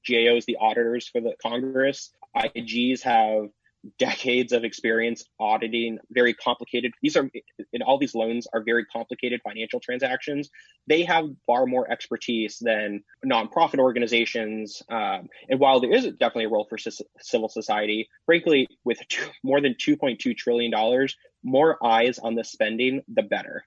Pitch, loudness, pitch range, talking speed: 120 Hz, -24 LUFS, 115-140 Hz, 150 wpm